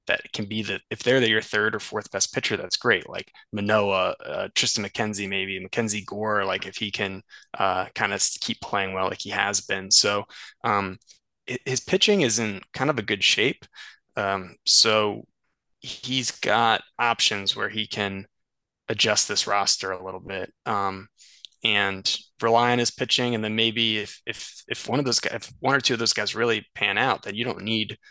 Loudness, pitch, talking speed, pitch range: -23 LUFS, 105 Hz, 195 wpm, 100-115 Hz